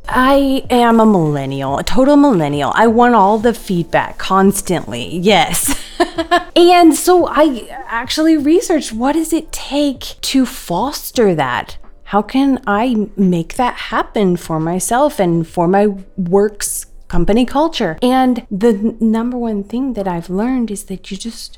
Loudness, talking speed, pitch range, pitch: -14 LUFS, 145 wpm, 195-270 Hz, 225 Hz